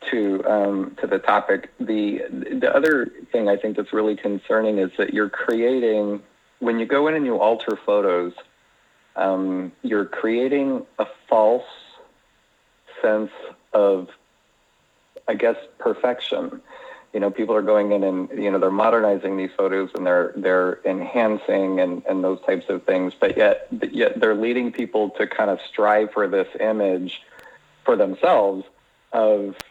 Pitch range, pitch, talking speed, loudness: 95-110 Hz, 105 Hz, 155 wpm, -21 LUFS